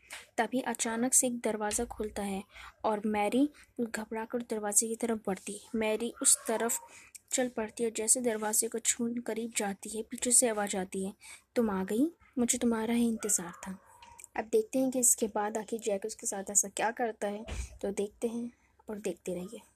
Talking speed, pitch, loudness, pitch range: 185 wpm, 225 Hz, -31 LUFS, 210-245 Hz